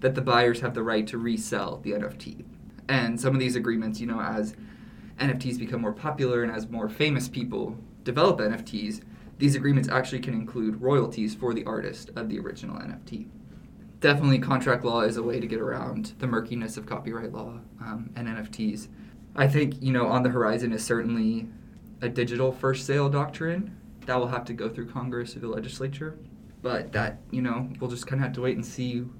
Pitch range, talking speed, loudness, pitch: 115-130 Hz, 195 wpm, -28 LUFS, 120 Hz